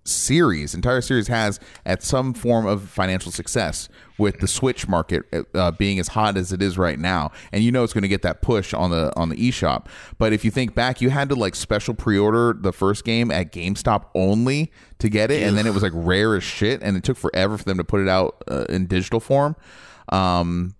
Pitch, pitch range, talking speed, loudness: 100 Hz, 95-115 Hz, 230 wpm, -21 LUFS